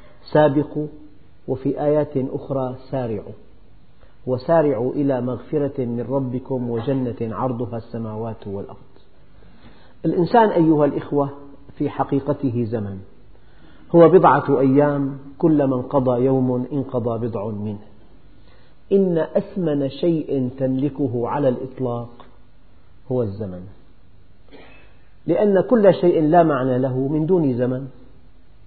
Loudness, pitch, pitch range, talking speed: -20 LUFS, 130 Hz, 120-145 Hz, 100 wpm